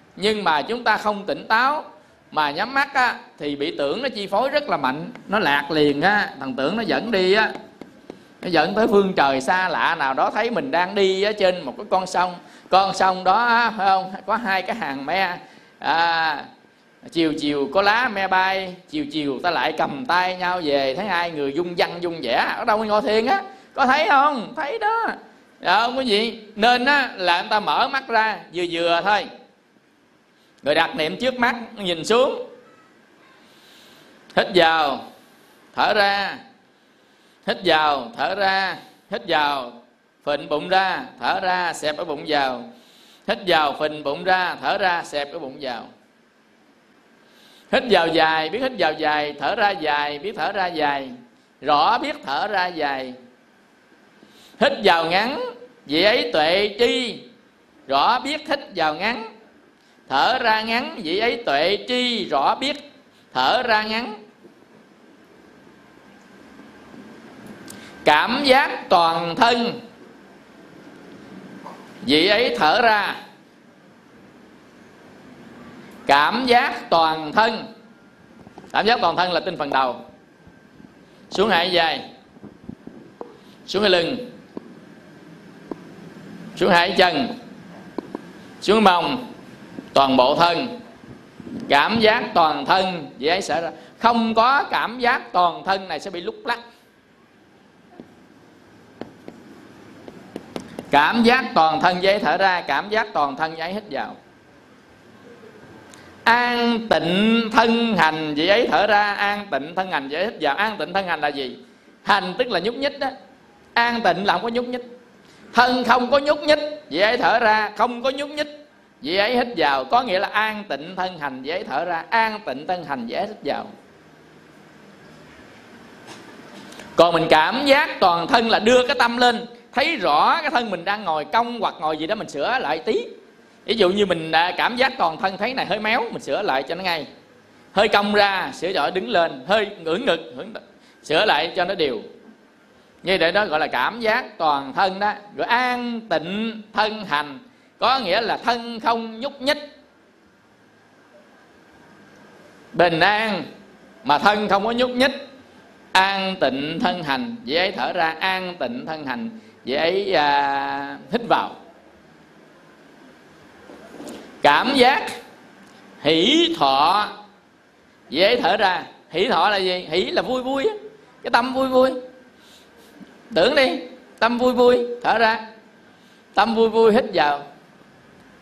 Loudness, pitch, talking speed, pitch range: -20 LUFS, 210 Hz, 155 wpm, 175-245 Hz